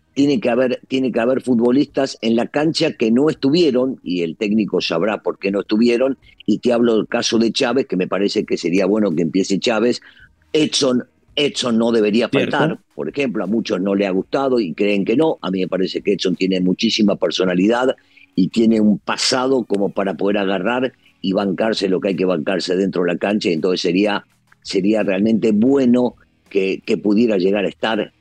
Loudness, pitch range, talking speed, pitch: -18 LUFS, 100-125 Hz, 200 wpm, 110 Hz